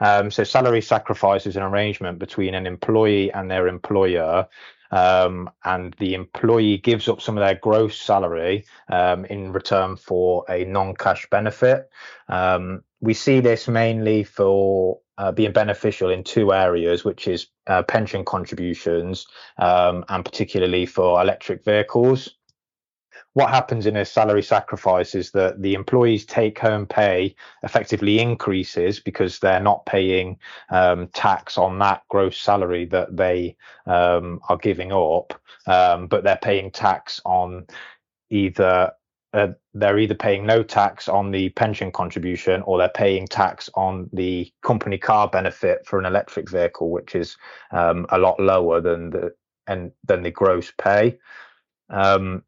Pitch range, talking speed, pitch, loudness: 90-110 Hz, 145 wpm, 95 Hz, -20 LUFS